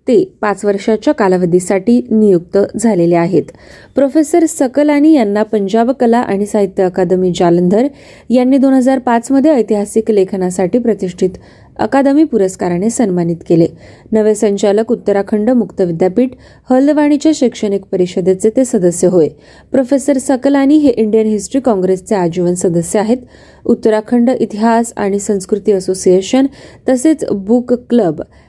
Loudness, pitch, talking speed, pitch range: -12 LUFS, 220 Hz, 115 wpm, 195-255 Hz